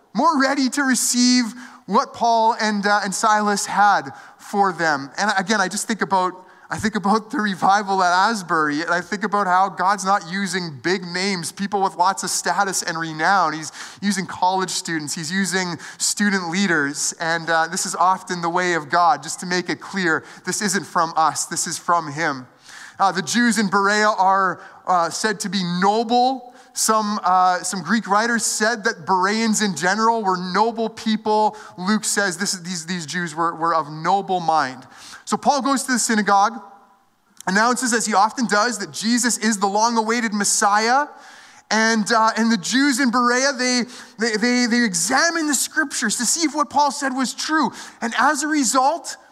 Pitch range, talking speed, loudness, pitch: 185-235 Hz, 185 wpm, -19 LUFS, 205 Hz